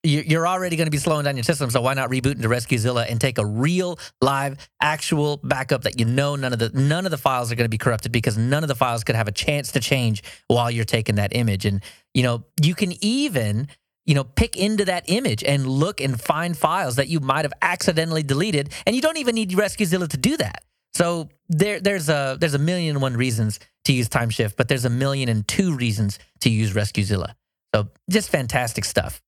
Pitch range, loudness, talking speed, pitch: 120-165 Hz, -22 LUFS, 230 wpm, 135 Hz